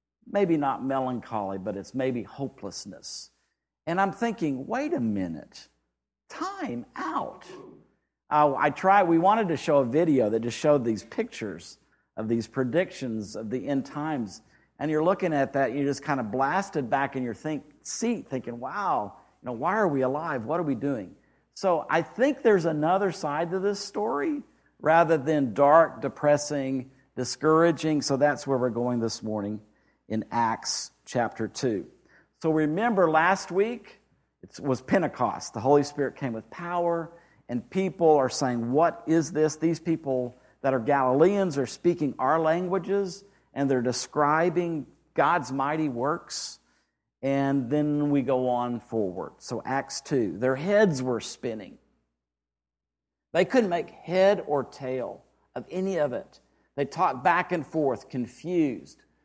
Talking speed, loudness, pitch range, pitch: 155 wpm, -26 LUFS, 125-170 Hz, 145 Hz